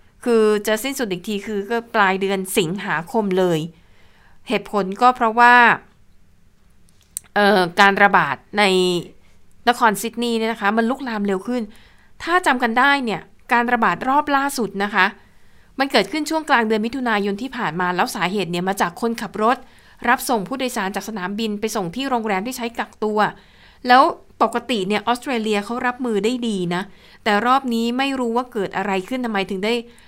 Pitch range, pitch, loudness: 195-240 Hz, 215 Hz, -19 LUFS